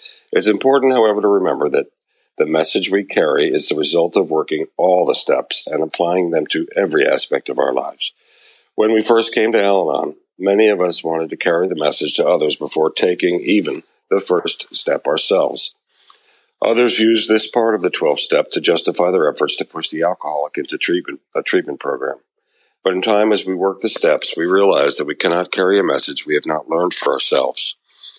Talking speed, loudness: 195 wpm, -16 LUFS